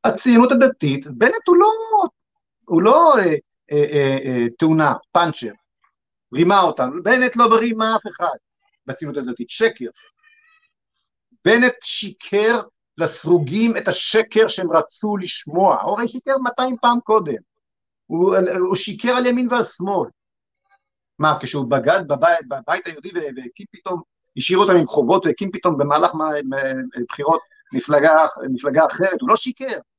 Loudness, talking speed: -17 LUFS, 135 wpm